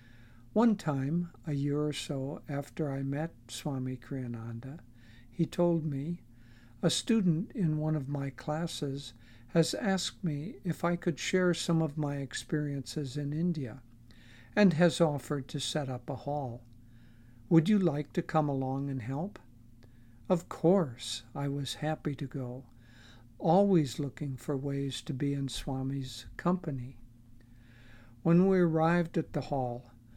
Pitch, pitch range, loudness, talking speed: 140 Hz, 120-160 Hz, -32 LUFS, 145 wpm